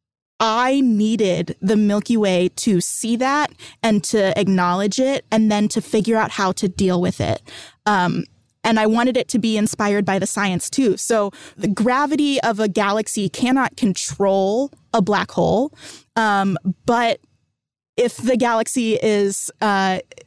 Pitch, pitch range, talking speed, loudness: 215 Hz, 195-235 Hz, 155 wpm, -19 LUFS